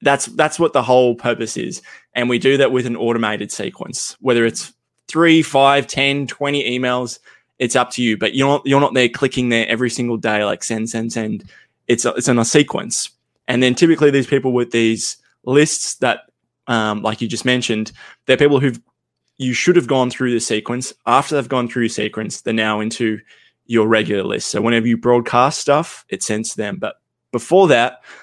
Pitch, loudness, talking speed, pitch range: 125 Hz, -17 LUFS, 200 wpm, 115-135 Hz